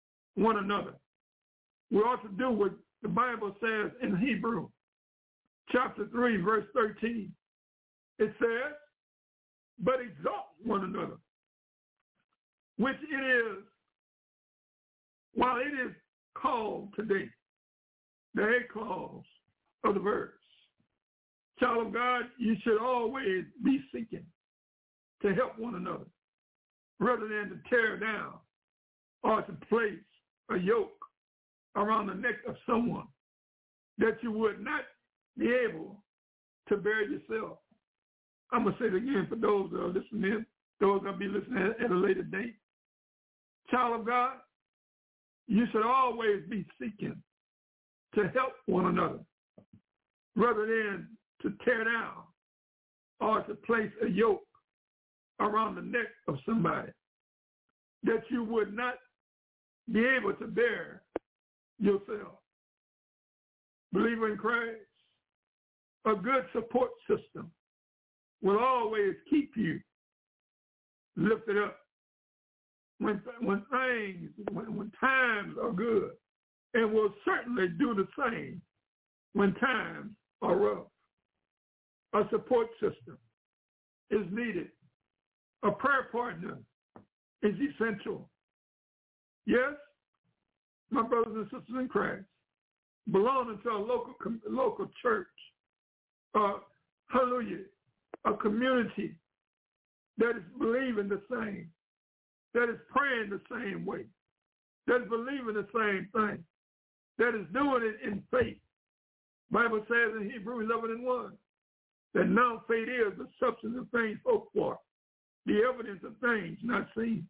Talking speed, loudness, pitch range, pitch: 120 wpm, -32 LUFS, 205-245 Hz, 225 Hz